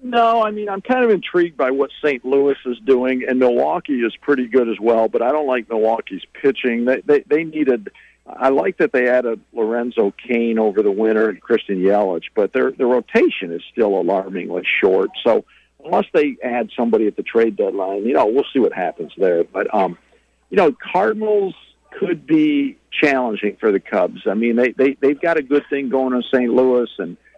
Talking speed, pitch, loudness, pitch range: 200 wpm, 130 Hz, -18 LUFS, 120-160 Hz